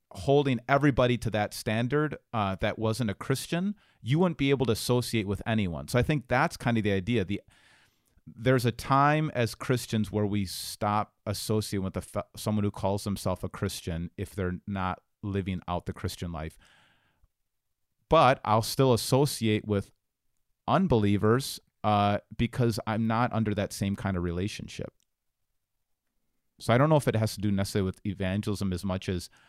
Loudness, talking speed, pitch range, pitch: -28 LUFS, 170 wpm, 100-120 Hz, 105 Hz